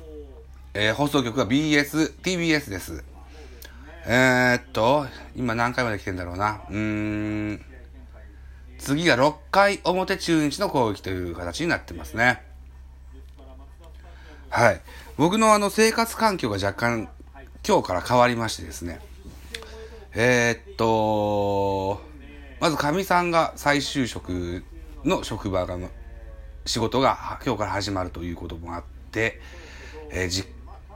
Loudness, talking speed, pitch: -23 LUFS, 200 characters per minute, 90 Hz